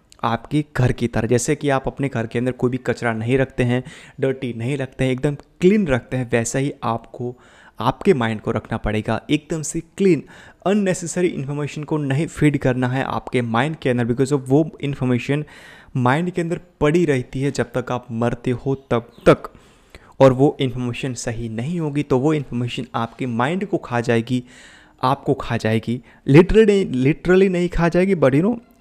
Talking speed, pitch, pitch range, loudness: 185 wpm, 130 Hz, 120-150 Hz, -20 LUFS